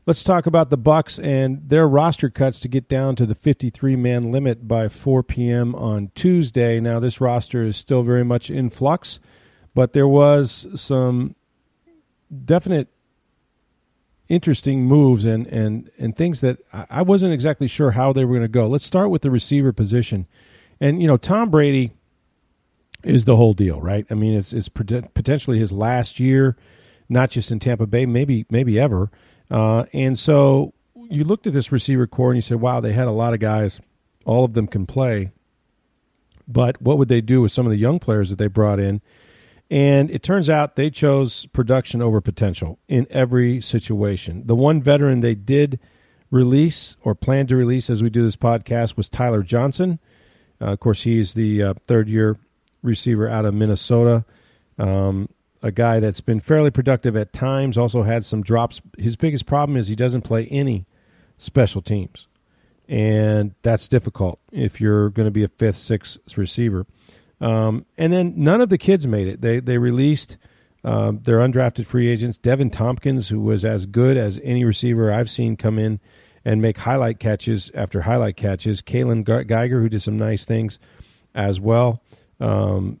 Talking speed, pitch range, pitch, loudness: 180 wpm, 110-135 Hz, 120 Hz, -19 LUFS